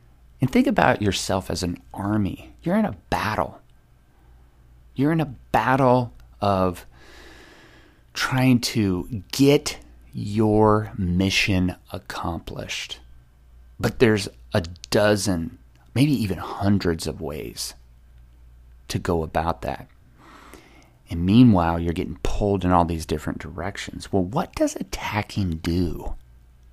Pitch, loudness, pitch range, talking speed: 90 Hz, -23 LUFS, 65-105 Hz, 110 wpm